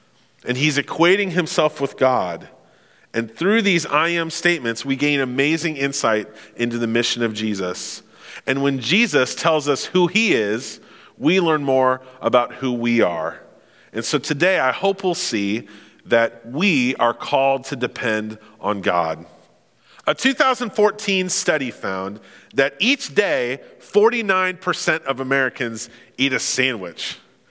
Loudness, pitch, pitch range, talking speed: -20 LUFS, 135 Hz, 115-175 Hz, 140 wpm